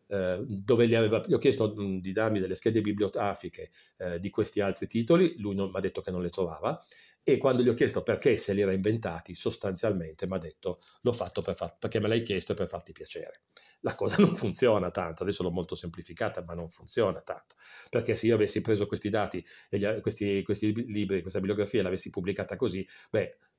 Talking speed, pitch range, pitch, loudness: 200 wpm, 95-110 Hz, 105 Hz, -30 LUFS